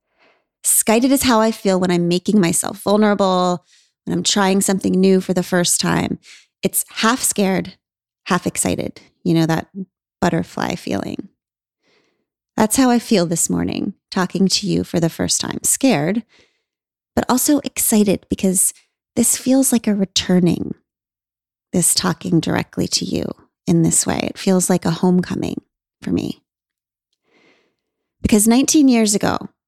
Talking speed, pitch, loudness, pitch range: 145 wpm, 195 Hz, -17 LUFS, 180-225 Hz